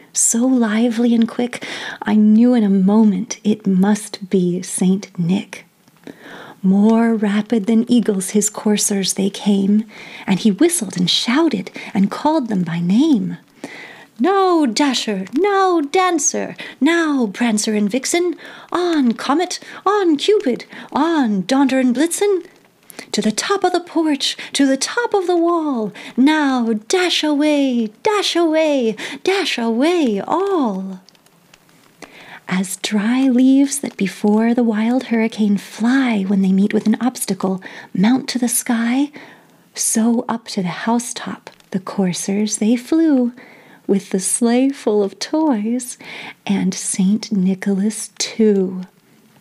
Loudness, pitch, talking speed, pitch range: -17 LUFS, 235 Hz, 130 wpm, 210-285 Hz